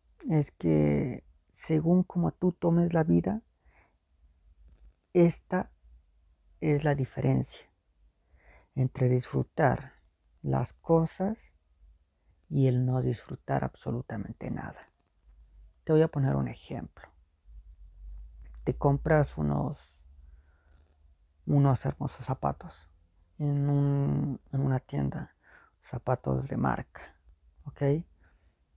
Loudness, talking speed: -29 LUFS, 90 wpm